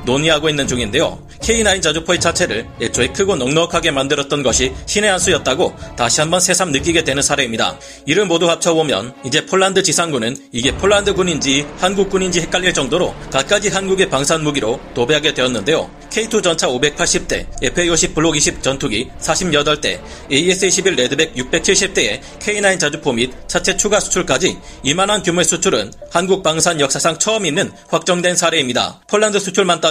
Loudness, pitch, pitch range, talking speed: -15 LUFS, 170 Hz, 140-190 Hz, 360 characters per minute